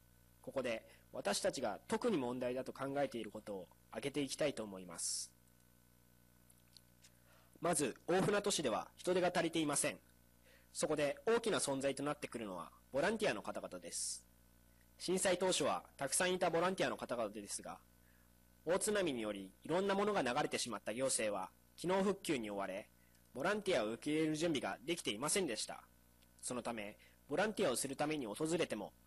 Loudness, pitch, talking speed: -39 LUFS, 110 Hz, 365 characters per minute